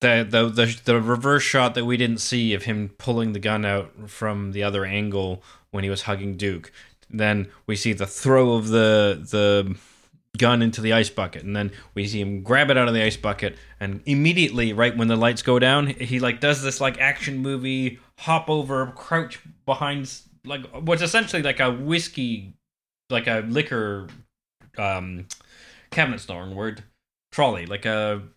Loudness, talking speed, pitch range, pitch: -22 LUFS, 180 wpm, 100-130 Hz, 115 Hz